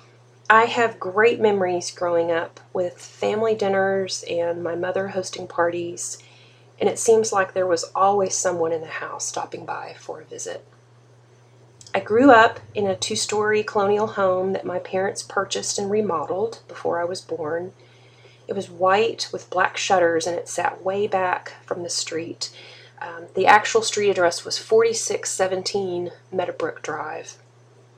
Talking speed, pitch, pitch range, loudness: 155 wpm, 185 Hz, 165-215 Hz, -22 LUFS